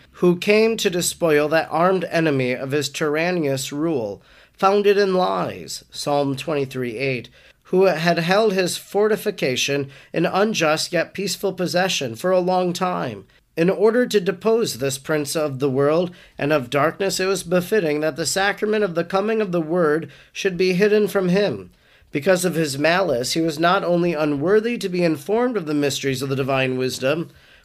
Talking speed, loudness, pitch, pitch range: 170 wpm, -20 LUFS, 170 Hz, 145-195 Hz